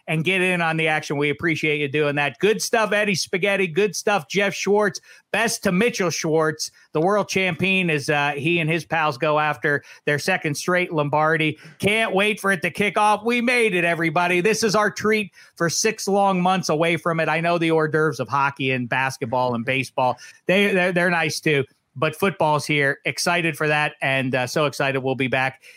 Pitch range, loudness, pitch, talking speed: 150-195 Hz, -21 LUFS, 165 Hz, 205 wpm